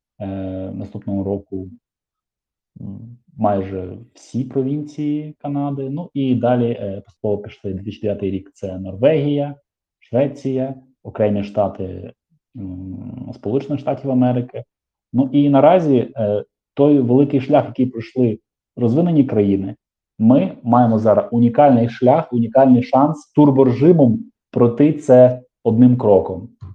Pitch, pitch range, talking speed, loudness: 125 Hz, 100-140 Hz, 110 wpm, -17 LUFS